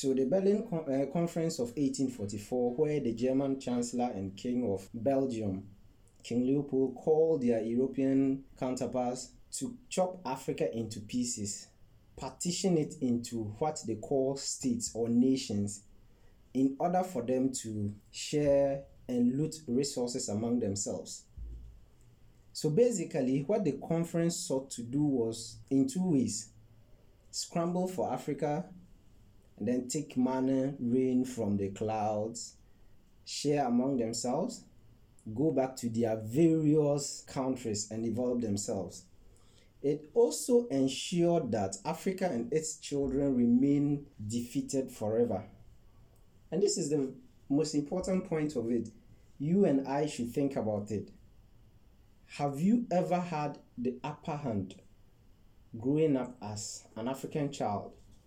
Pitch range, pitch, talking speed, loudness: 110-150 Hz, 130 Hz, 125 wpm, -32 LUFS